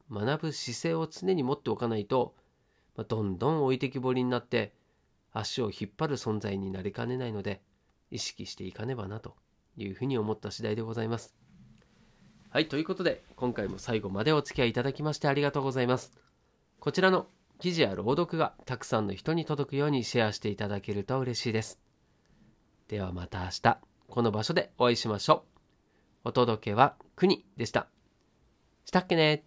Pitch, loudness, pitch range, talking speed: 120 Hz, -31 LUFS, 105-145 Hz, 365 characters per minute